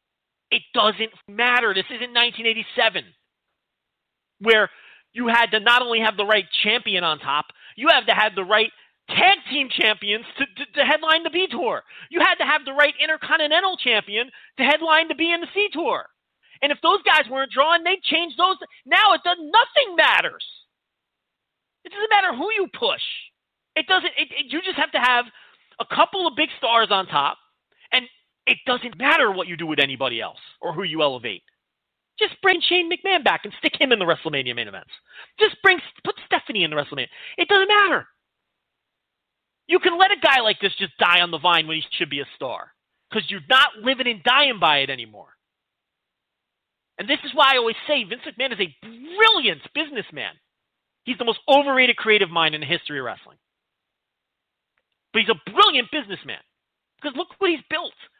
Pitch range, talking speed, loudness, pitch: 215-335 Hz, 190 wpm, -19 LUFS, 270 Hz